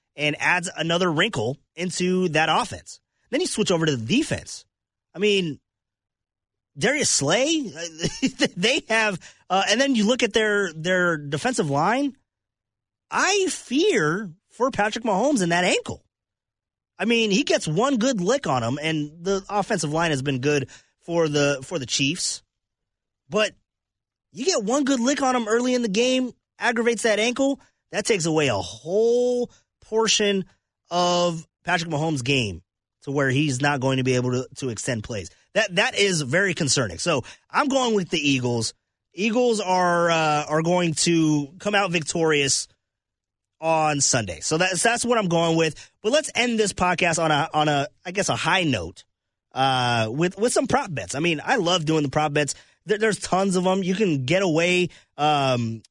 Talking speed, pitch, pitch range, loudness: 175 wpm, 170 Hz, 140-210 Hz, -22 LUFS